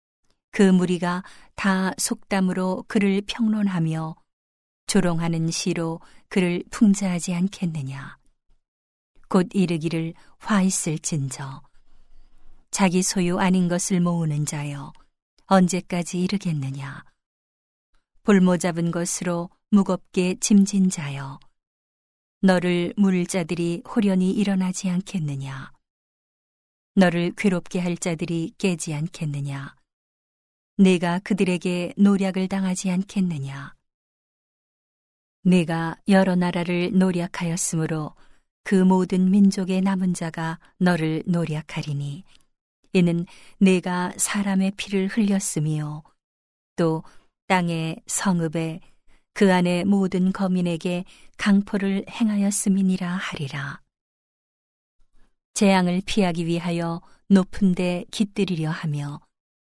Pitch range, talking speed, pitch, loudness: 165-195 Hz, 215 characters per minute, 180 Hz, -23 LUFS